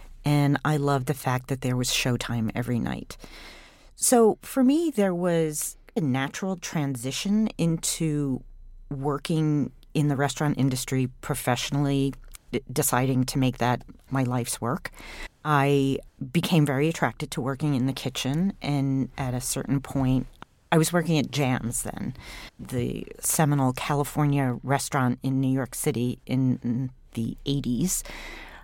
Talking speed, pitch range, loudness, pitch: 140 wpm, 130-150 Hz, -26 LUFS, 140 Hz